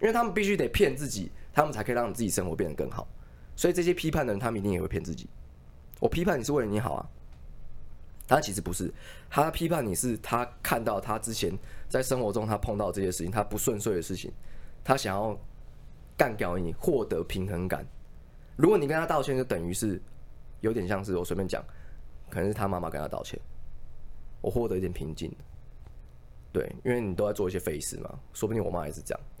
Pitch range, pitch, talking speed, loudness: 70-115 Hz, 95 Hz, 315 characters per minute, -30 LUFS